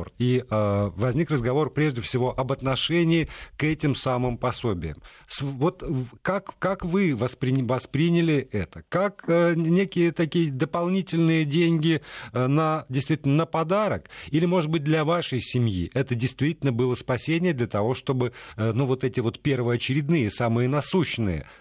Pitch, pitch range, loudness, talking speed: 140 Hz, 125-165 Hz, -25 LUFS, 145 wpm